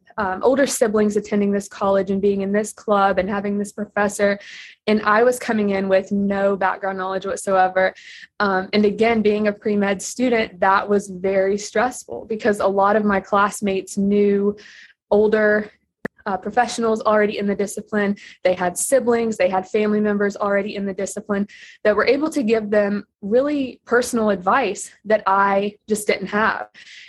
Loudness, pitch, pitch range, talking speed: -20 LUFS, 205 Hz, 200-215 Hz, 170 wpm